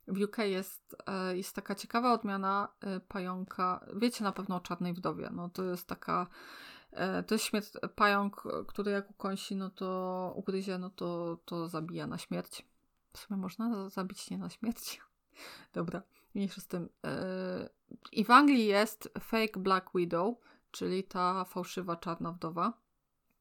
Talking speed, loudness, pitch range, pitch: 150 wpm, -34 LUFS, 185-205 Hz, 195 Hz